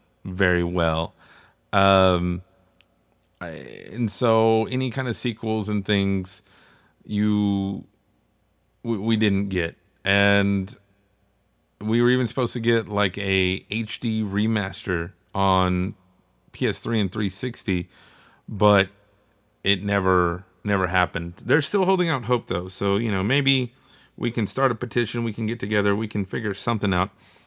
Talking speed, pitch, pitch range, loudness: 135 wpm, 100 Hz, 95-115 Hz, -23 LUFS